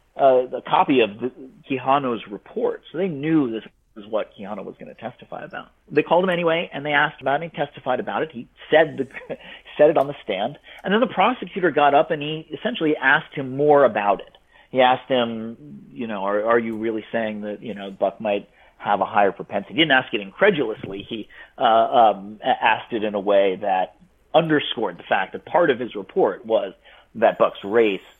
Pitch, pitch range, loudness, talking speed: 130 Hz, 110-150 Hz, -21 LUFS, 210 wpm